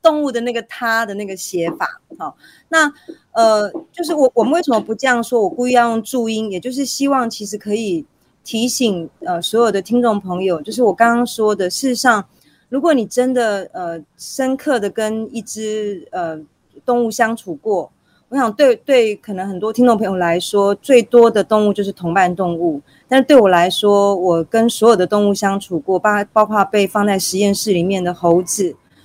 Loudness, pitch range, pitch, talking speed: -16 LUFS, 195-245 Hz, 220 Hz, 280 characters per minute